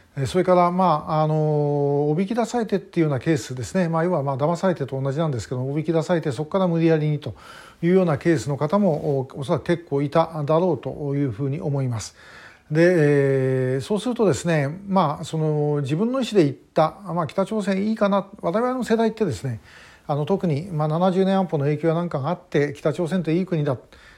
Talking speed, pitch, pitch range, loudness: 405 characters per minute, 160 Hz, 145-185 Hz, -22 LUFS